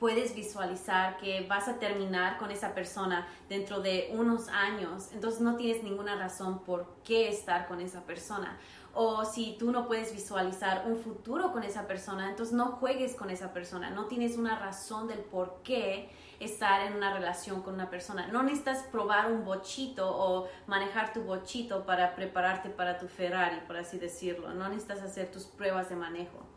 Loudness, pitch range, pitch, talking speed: -34 LUFS, 185-220 Hz, 195 Hz, 180 wpm